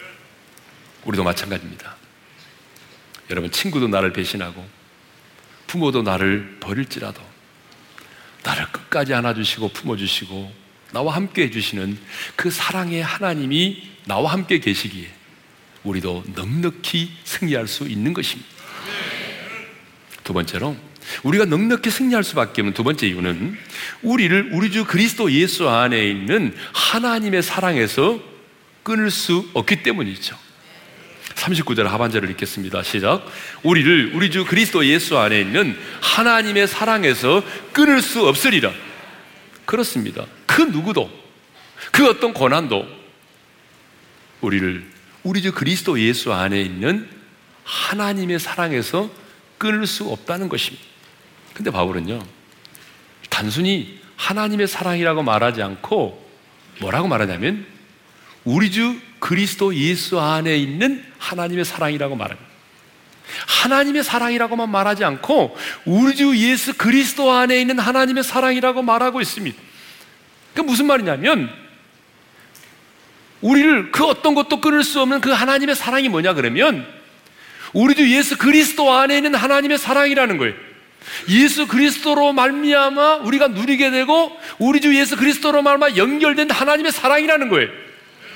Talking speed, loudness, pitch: 300 characters per minute, -18 LUFS, 200 Hz